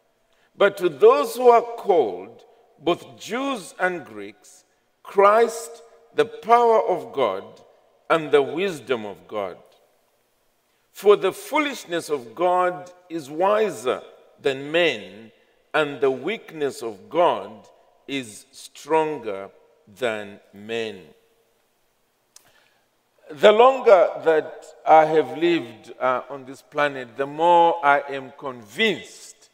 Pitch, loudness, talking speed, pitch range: 170 Hz, -21 LUFS, 110 wpm, 140-230 Hz